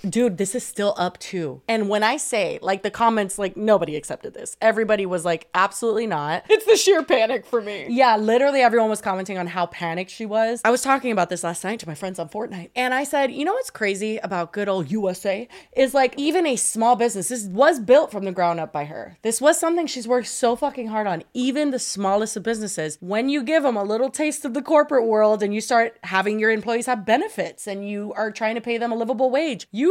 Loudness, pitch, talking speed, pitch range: -21 LUFS, 225 Hz, 240 wpm, 195-255 Hz